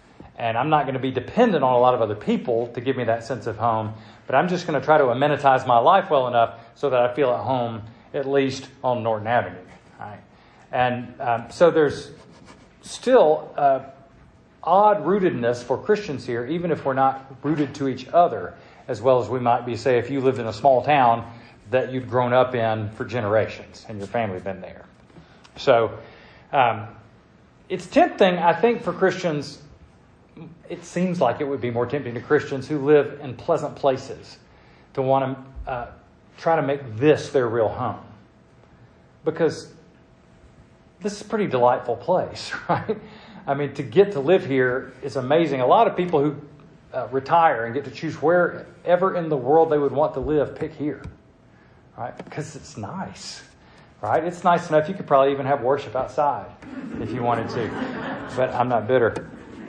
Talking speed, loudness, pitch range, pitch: 185 wpm, -22 LUFS, 125-160 Hz, 140 Hz